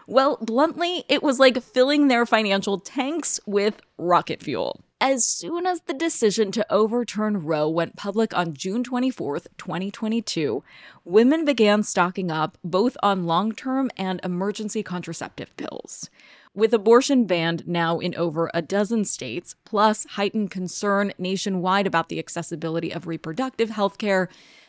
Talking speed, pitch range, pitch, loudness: 140 wpm, 180-245 Hz, 205 Hz, -23 LUFS